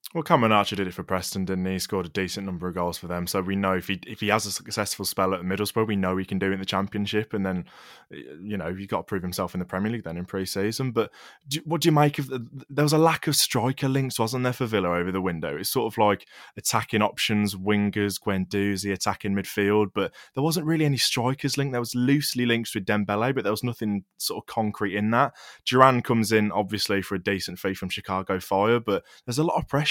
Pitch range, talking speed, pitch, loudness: 95-125 Hz, 260 wpm, 105 Hz, -25 LUFS